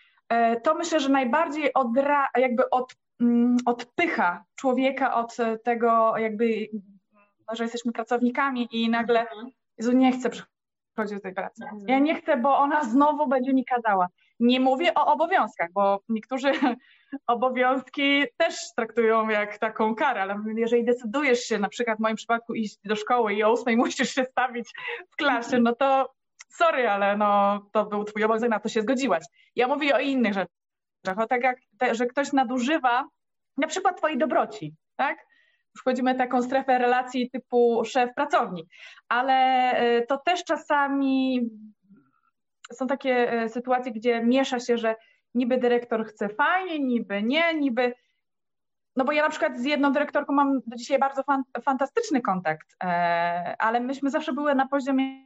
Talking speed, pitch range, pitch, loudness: 150 wpm, 225-275 Hz, 250 Hz, -24 LUFS